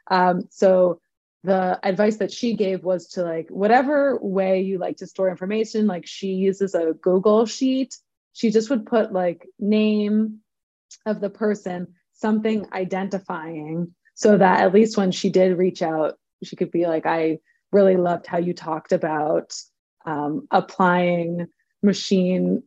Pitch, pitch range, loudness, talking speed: 190 Hz, 180-210 Hz, -21 LUFS, 150 wpm